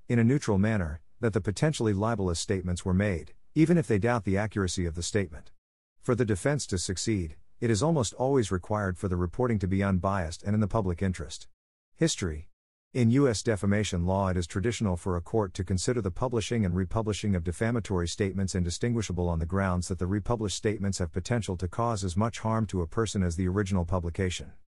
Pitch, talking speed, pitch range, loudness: 100 Hz, 200 wpm, 90-115 Hz, -29 LUFS